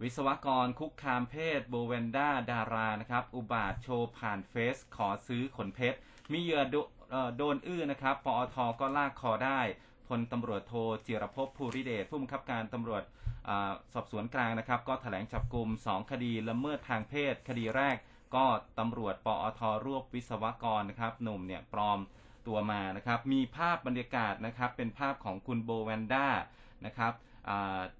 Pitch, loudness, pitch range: 120 Hz, -35 LUFS, 110-130 Hz